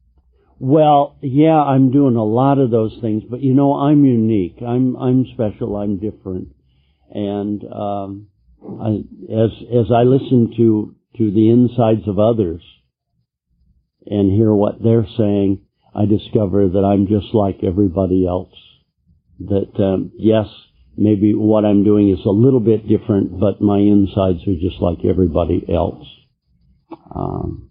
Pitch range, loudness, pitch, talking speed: 95-115 Hz, -16 LUFS, 105 Hz, 145 wpm